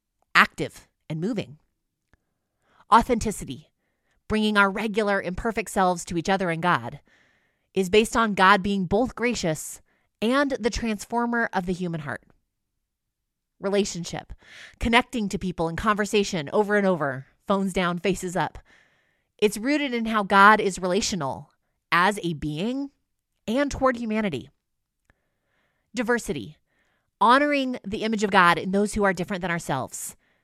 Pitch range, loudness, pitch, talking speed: 180-225 Hz, -23 LUFS, 200 Hz, 130 wpm